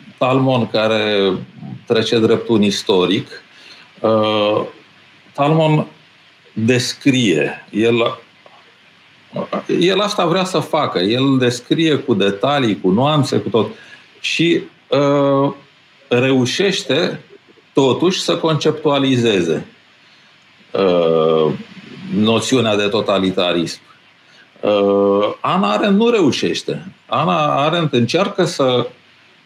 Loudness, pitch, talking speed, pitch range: -16 LUFS, 125 Hz, 85 wpm, 110-155 Hz